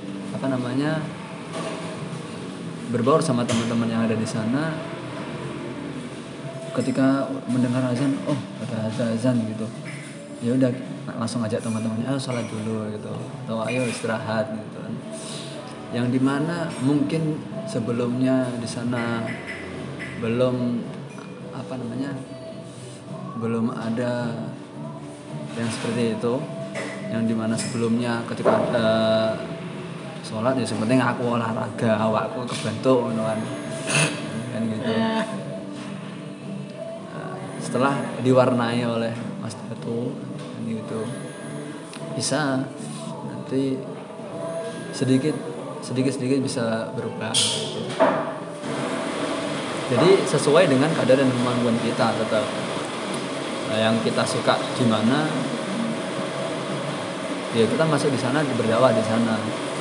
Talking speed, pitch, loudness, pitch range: 90 wpm, 125 Hz, -24 LUFS, 115-135 Hz